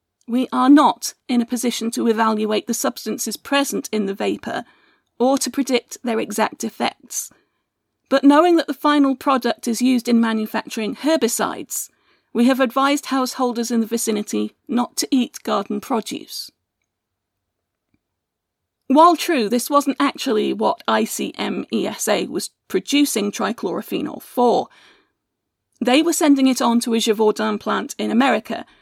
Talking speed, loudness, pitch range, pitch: 135 wpm, -19 LUFS, 220-275 Hz, 240 Hz